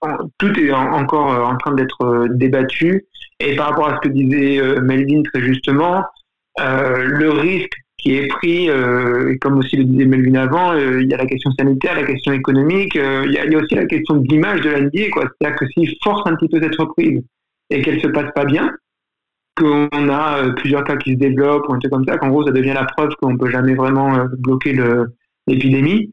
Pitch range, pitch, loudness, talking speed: 130-150 Hz, 140 Hz, -16 LUFS, 225 wpm